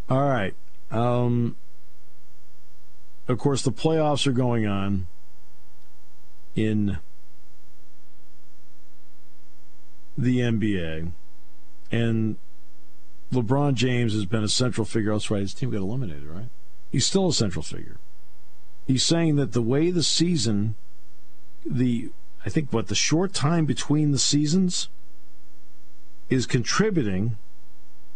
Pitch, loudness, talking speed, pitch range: 95 Hz, -24 LUFS, 110 wpm, 75-125 Hz